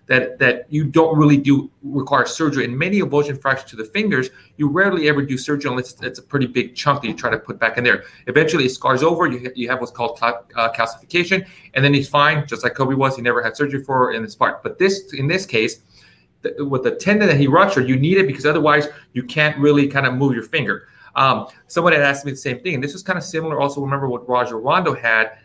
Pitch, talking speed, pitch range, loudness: 140 Hz, 250 wpm, 125-150 Hz, -18 LUFS